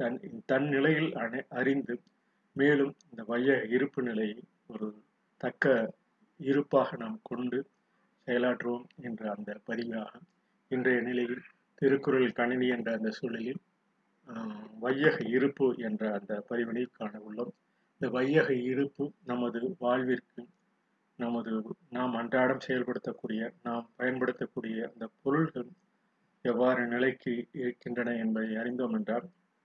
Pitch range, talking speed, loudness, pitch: 120-140 Hz, 105 wpm, -32 LUFS, 125 Hz